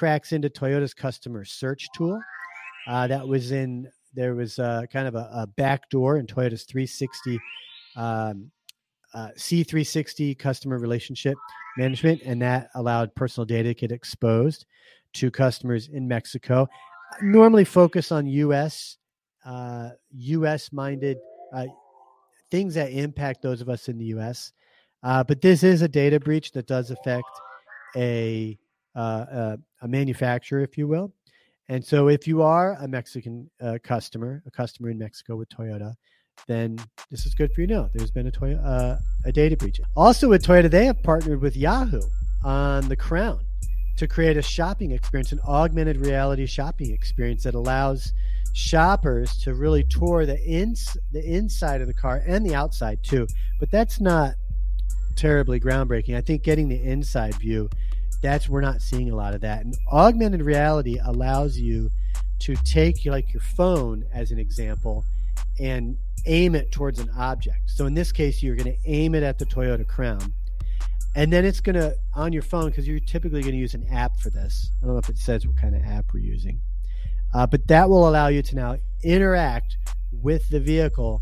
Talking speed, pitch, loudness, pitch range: 175 wpm, 130 Hz, -24 LUFS, 115-150 Hz